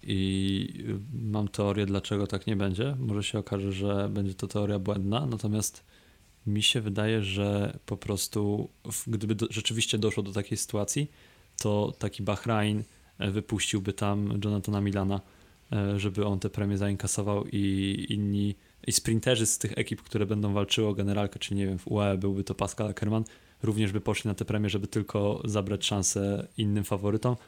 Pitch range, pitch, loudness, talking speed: 100-110 Hz, 105 Hz, -30 LUFS, 160 wpm